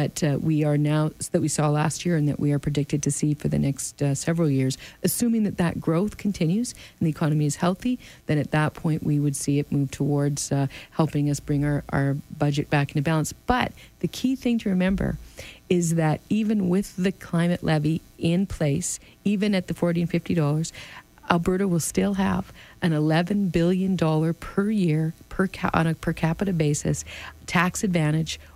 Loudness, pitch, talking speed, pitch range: -24 LUFS, 160 Hz, 200 wpm, 145-185 Hz